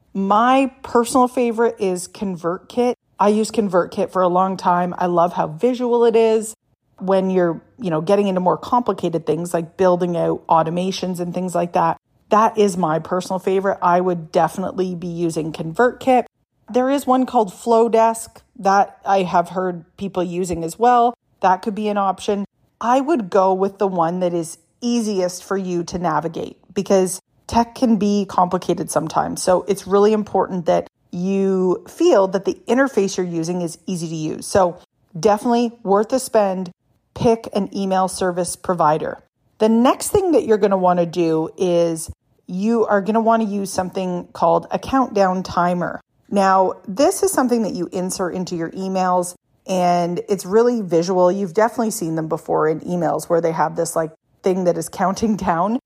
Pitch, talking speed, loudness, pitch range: 190 Hz, 175 wpm, -19 LUFS, 175-220 Hz